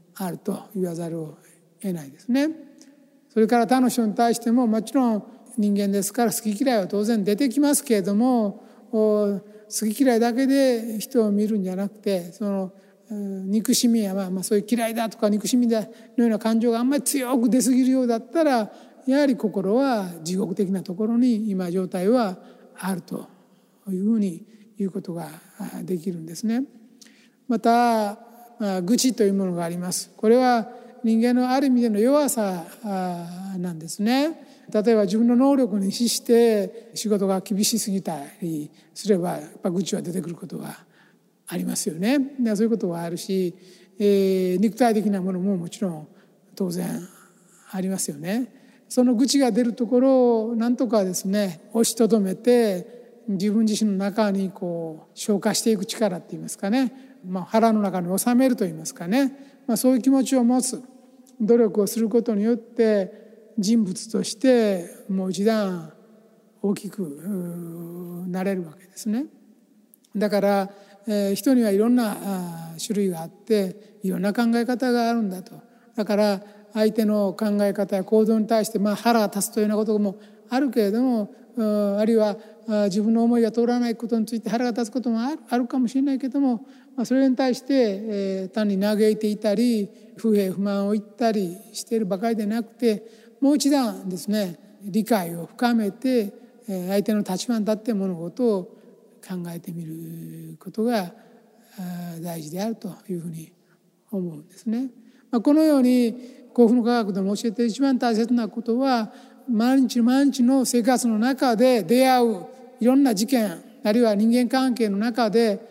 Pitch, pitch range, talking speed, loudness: 220 Hz, 195-240 Hz, 320 characters per minute, -23 LUFS